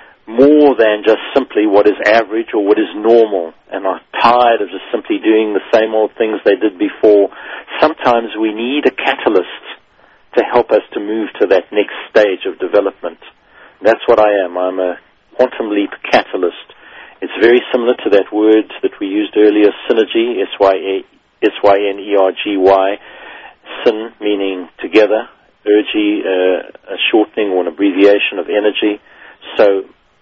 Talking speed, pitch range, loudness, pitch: 150 wpm, 100-125 Hz, -13 LUFS, 110 Hz